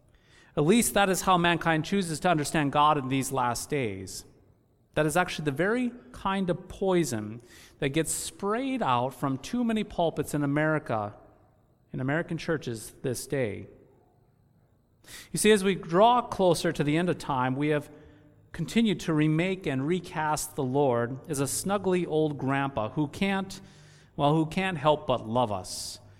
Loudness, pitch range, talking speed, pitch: -27 LUFS, 130-175 Hz, 165 wpm, 150 Hz